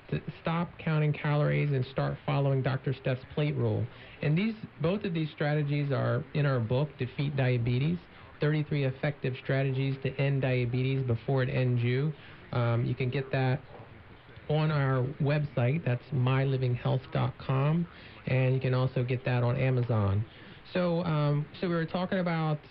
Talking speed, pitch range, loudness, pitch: 150 wpm, 125-150 Hz, -30 LUFS, 135 Hz